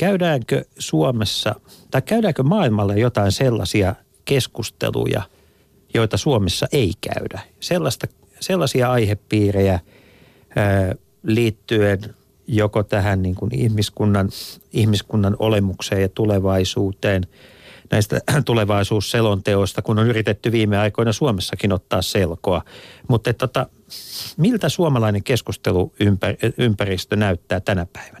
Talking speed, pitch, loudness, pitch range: 90 wpm, 110 Hz, -20 LUFS, 100-125 Hz